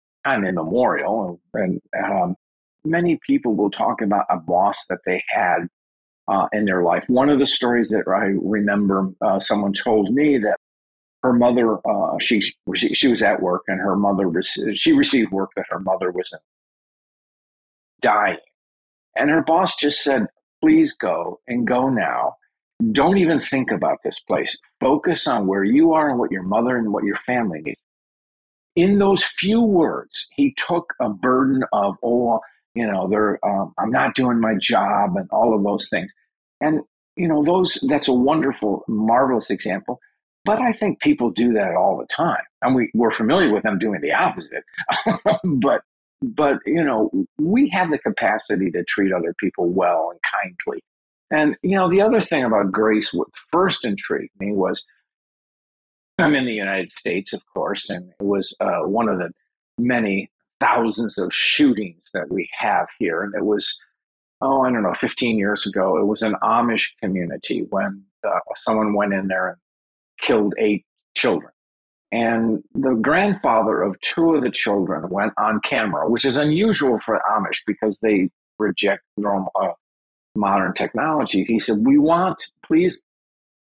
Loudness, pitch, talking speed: -20 LUFS, 115 Hz, 170 wpm